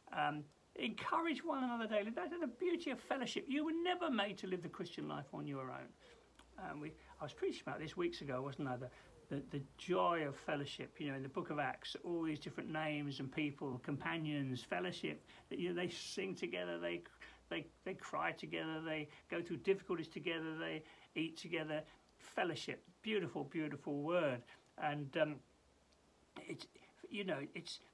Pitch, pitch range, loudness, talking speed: 155 Hz, 145-180 Hz, -43 LUFS, 180 wpm